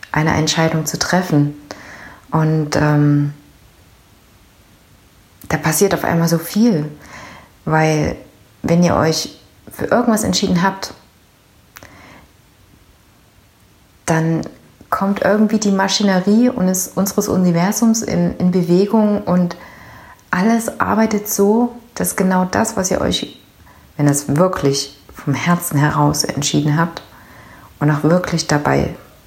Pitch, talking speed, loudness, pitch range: 170 Hz, 110 wpm, -16 LUFS, 150-195 Hz